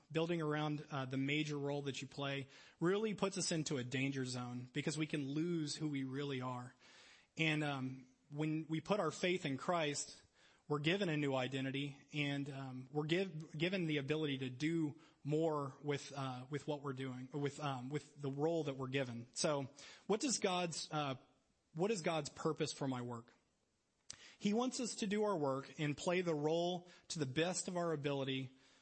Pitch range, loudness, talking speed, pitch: 135-165 Hz, -40 LUFS, 190 wpm, 150 Hz